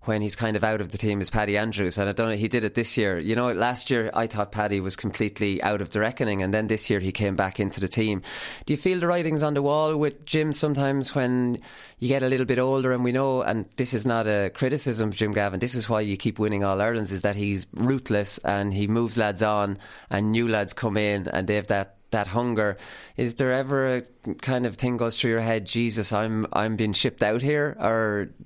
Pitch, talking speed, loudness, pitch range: 110 Hz, 250 wpm, -25 LUFS, 105-125 Hz